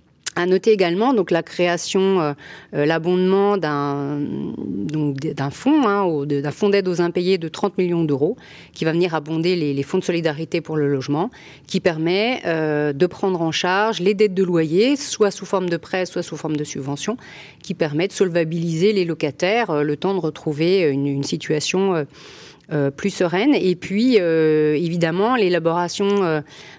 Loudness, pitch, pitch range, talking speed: -20 LUFS, 170 Hz, 155-190 Hz, 175 wpm